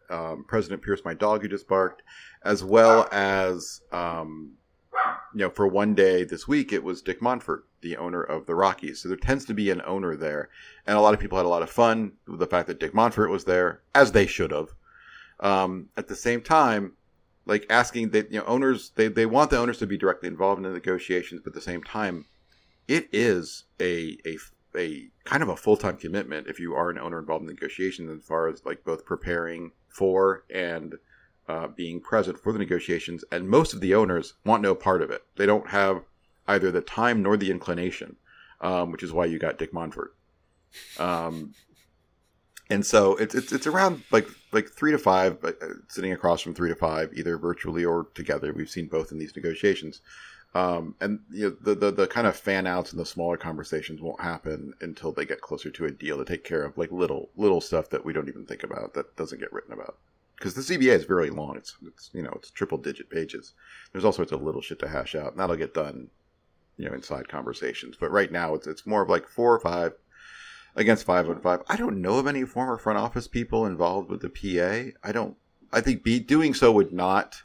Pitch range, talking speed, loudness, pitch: 85-105 Hz, 220 wpm, -26 LUFS, 95 Hz